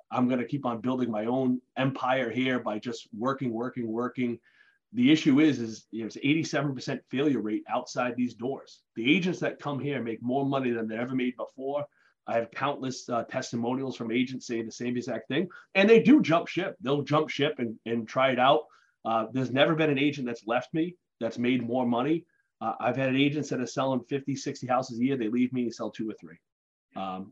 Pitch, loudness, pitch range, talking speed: 130 Hz, -28 LUFS, 120-145 Hz, 215 wpm